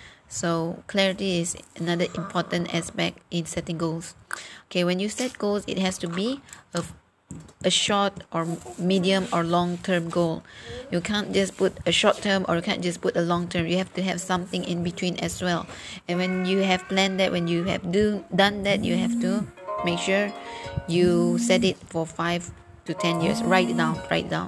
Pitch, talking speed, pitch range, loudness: 180 Hz, 195 wpm, 170-195 Hz, -25 LUFS